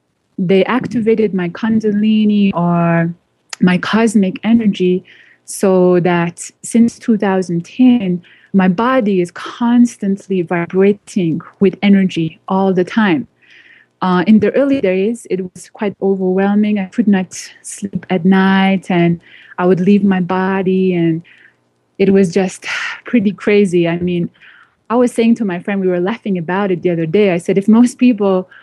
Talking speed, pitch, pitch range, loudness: 145 wpm, 195 Hz, 180-215 Hz, -14 LUFS